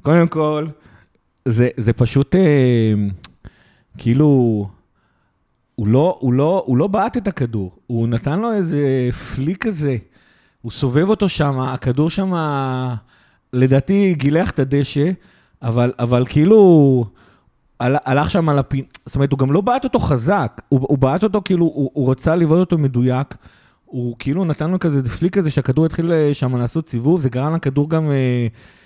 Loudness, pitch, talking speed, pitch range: -17 LUFS, 140 Hz, 150 wpm, 125-160 Hz